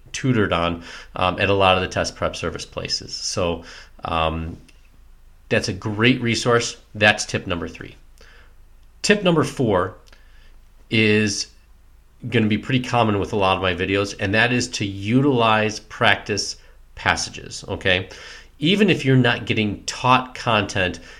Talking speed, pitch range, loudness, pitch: 145 wpm, 85-120 Hz, -20 LUFS, 105 Hz